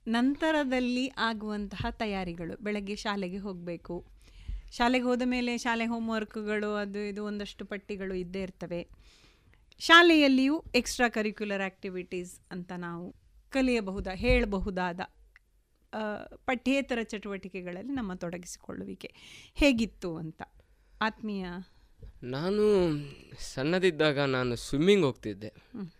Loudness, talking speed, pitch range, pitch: -29 LUFS, 85 wpm, 180-230 Hz, 205 Hz